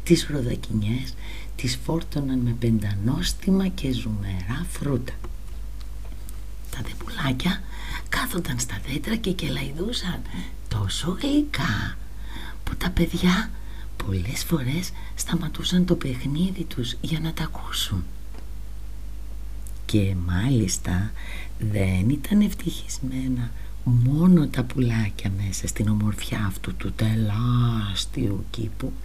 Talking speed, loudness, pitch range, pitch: 95 wpm, -25 LUFS, 100-155 Hz, 120 Hz